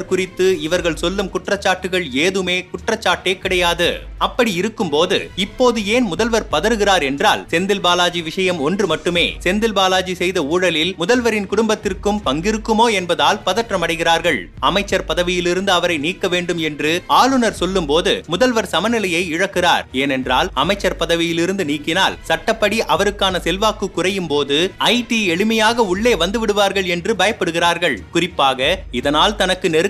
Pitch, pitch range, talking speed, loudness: 185 Hz, 170-210 Hz, 125 wpm, -17 LUFS